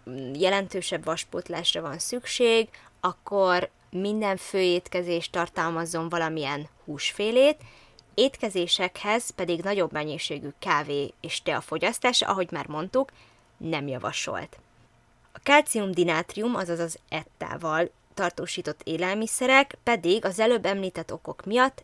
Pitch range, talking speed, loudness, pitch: 165-215 Hz, 100 wpm, -26 LUFS, 180 Hz